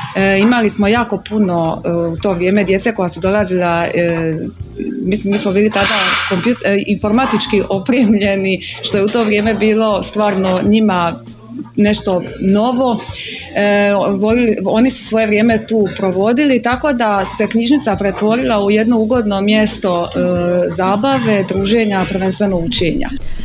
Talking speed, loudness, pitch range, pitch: 120 wpm, -14 LUFS, 190-220 Hz, 205 Hz